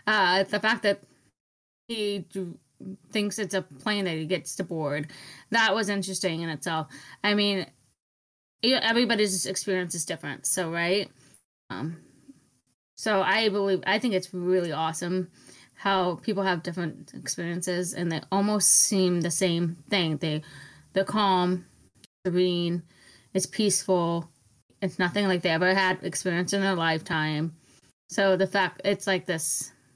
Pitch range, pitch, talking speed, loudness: 165-195 Hz, 185 Hz, 140 wpm, -26 LUFS